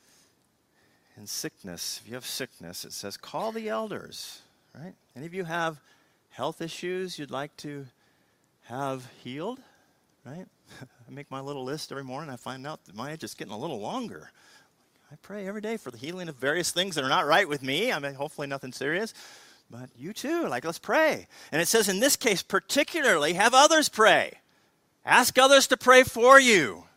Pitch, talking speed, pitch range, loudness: 165 Hz, 190 wpm, 140-225 Hz, -24 LUFS